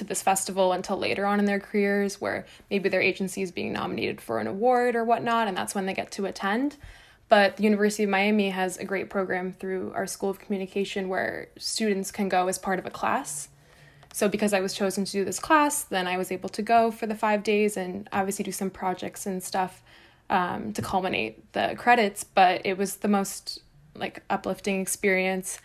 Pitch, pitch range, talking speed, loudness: 195 Hz, 190-210 Hz, 210 wpm, -26 LUFS